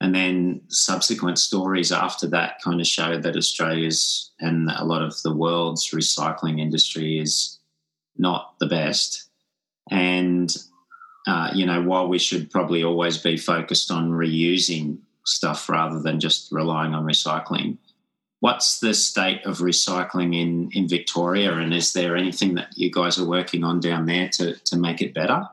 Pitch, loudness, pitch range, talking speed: 85 Hz, -22 LUFS, 80-90 Hz, 160 wpm